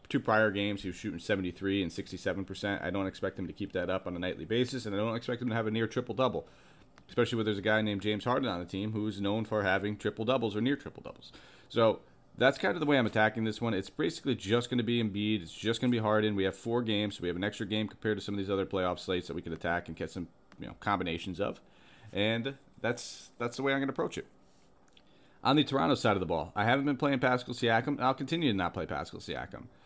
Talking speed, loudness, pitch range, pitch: 270 wpm, -32 LUFS, 100-120 Hz, 110 Hz